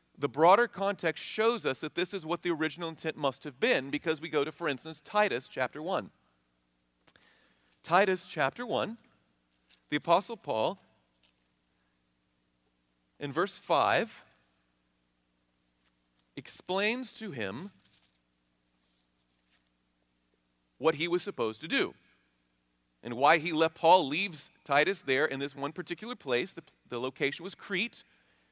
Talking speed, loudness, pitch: 125 wpm, -30 LUFS, 125 Hz